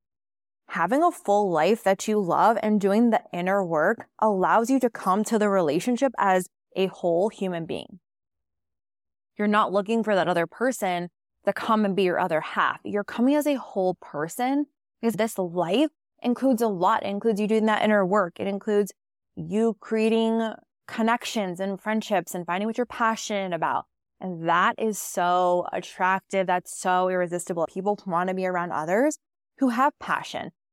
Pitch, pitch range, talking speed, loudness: 200 Hz, 180-225 Hz, 170 wpm, -25 LUFS